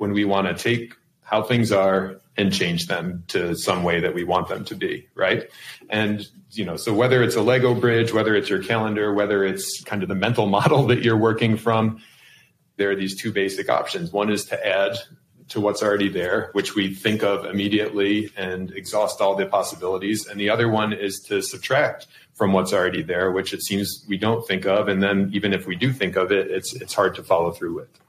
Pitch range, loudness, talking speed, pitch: 100-115 Hz, -22 LUFS, 220 wpm, 105 Hz